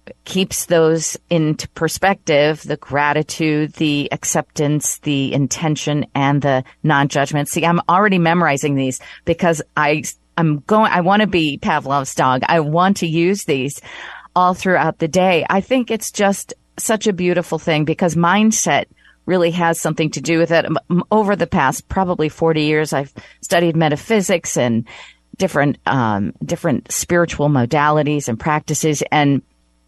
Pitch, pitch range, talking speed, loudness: 160 Hz, 145-175 Hz, 145 wpm, -17 LUFS